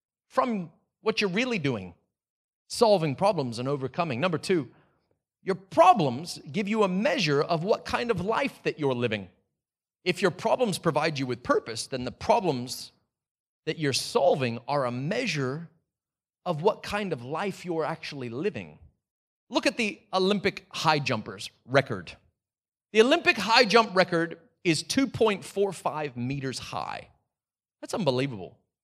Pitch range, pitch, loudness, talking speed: 125-195 Hz, 155 Hz, -27 LUFS, 140 wpm